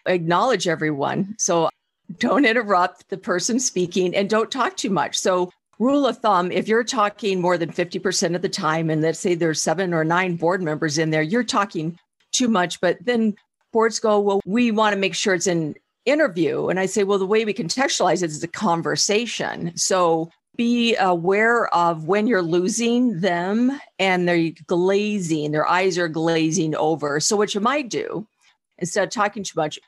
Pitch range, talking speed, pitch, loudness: 170-220 Hz, 185 wpm, 190 Hz, -21 LUFS